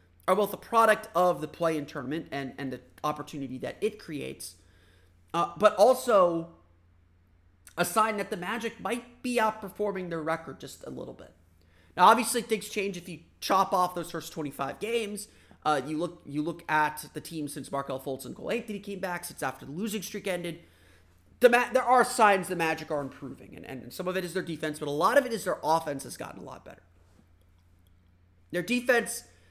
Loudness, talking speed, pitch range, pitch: -28 LUFS, 205 wpm, 130-205 Hz, 165 Hz